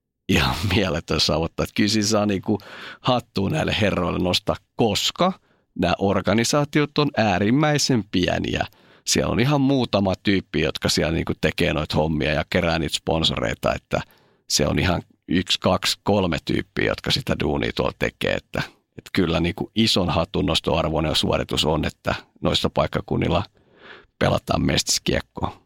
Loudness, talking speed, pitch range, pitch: -22 LUFS, 145 wpm, 85-115 Hz, 100 Hz